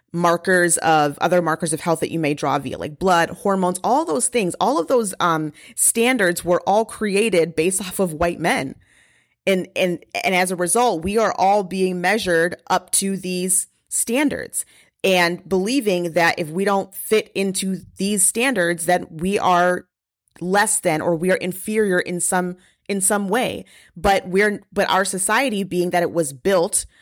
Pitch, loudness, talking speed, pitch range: 185 Hz, -19 LUFS, 175 wpm, 175-200 Hz